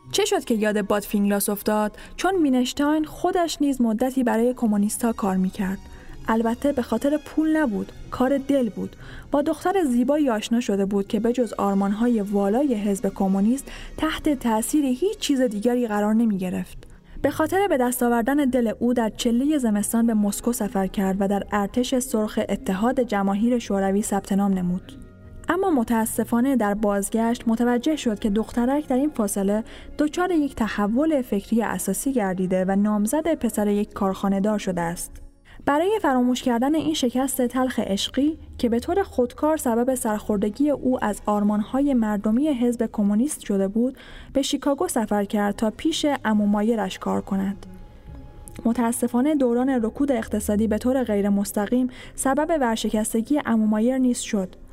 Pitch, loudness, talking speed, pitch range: 230 Hz, -23 LUFS, 145 wpm, 205-265 Hz